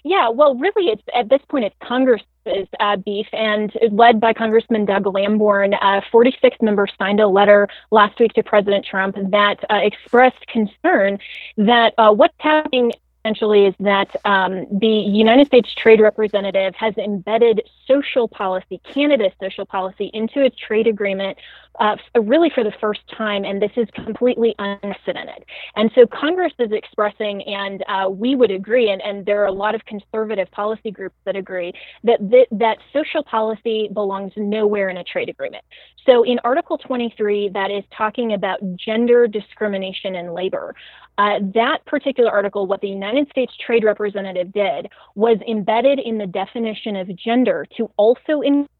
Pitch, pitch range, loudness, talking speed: 215 Hz, 200-240 Hz, -18 LUFS, 165 wpm